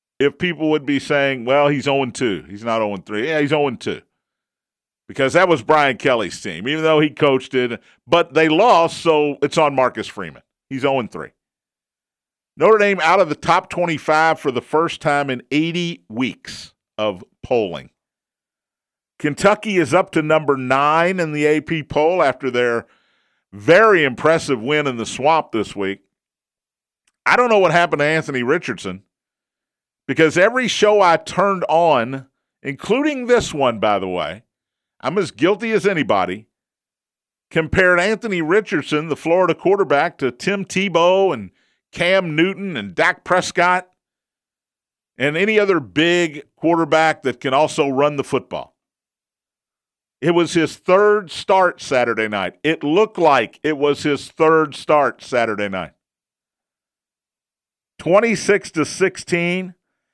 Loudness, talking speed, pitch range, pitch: -17 LUFS, 145 wpm, 135-180 Hz, 155 Hz